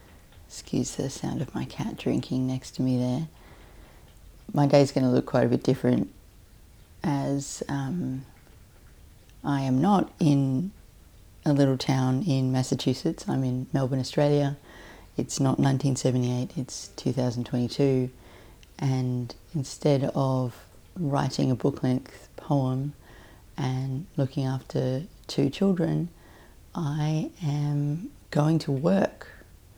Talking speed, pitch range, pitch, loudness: 115 wpm, 110-140 Hz, 130 Hz, -27 LUFS